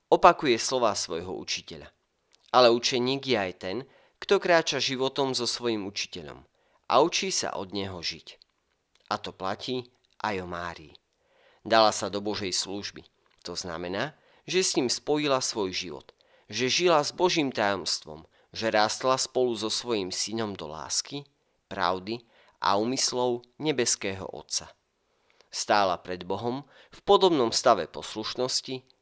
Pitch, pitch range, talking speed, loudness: 115 Hz, 95-130 Hz, 135 wpm, -27 LUFS